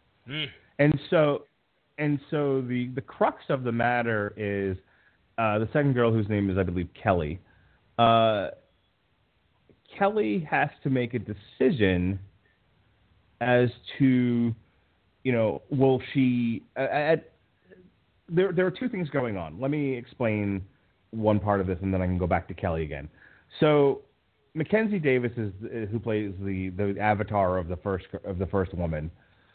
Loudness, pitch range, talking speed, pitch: -27 LUFS, 95-130 Hz, 155 wpm, 110 Hz